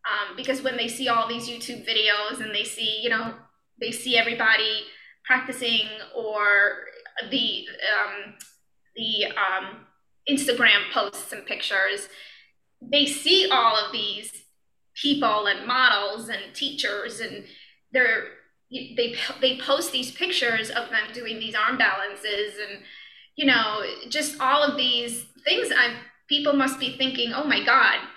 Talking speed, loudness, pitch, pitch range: 140 wpm, -23 LUFS, 235 Hz, 215-265 Hz